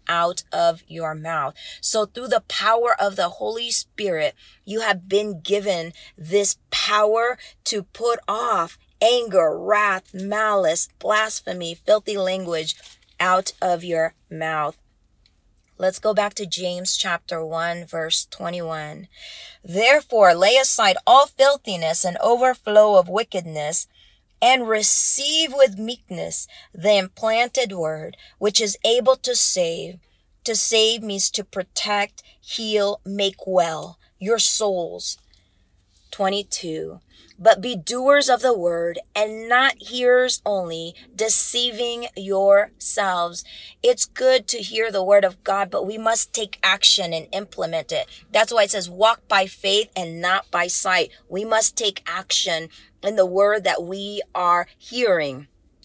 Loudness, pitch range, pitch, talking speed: -20 LUFS, 175-230 Hz, 200 Hz, 130 wpm